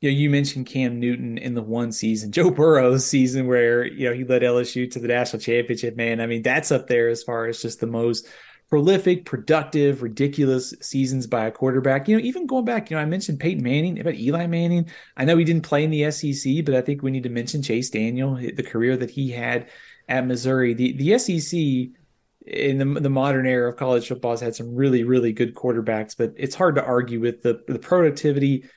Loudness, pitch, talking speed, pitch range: -22 LUFS, 130 Hz, 220 wpm, 120-145 Hz